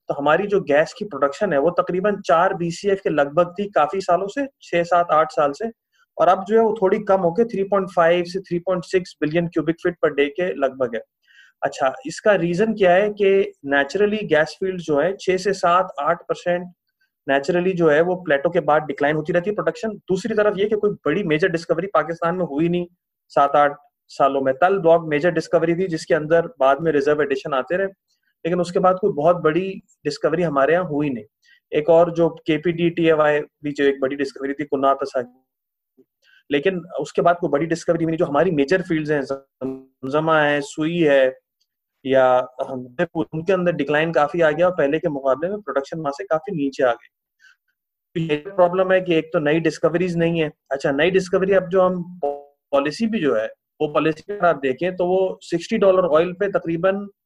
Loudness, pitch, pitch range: -20 LUFS, 170 Hz, 145-185 Hz